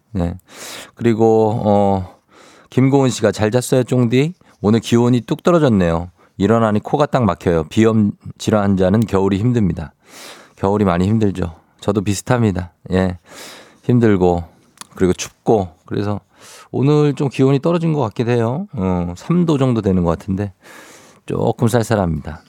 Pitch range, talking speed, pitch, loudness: 95-125 Hz, 290 characters per minute, 105 Hz, -17 LUFS